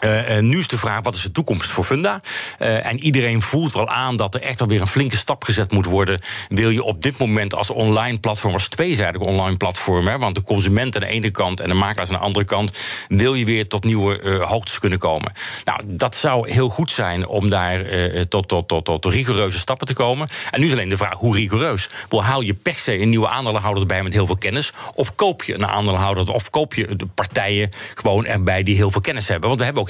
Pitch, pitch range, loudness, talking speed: 105 Hz, 100-120 Hz, -19 LUFS, 245 wpm